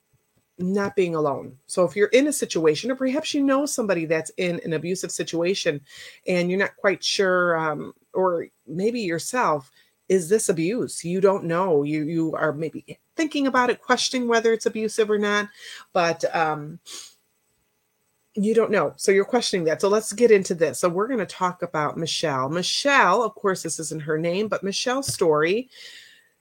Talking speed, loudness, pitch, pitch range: 175 wpm, -23 LUFS, 190 Hz, 165-225 Hz